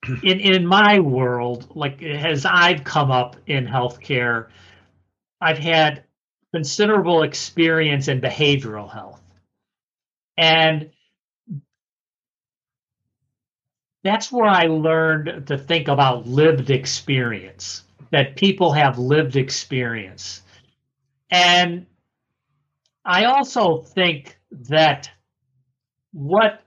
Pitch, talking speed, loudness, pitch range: 140 Hz, 90 wpm, -18 LUFS, 125-165 Hz